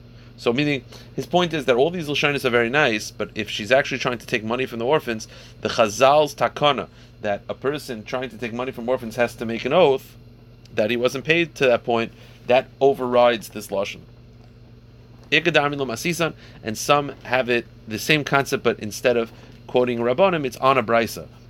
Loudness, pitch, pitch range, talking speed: -21 LUFS, 120 Hz, 115-135 Hz, 180 wpm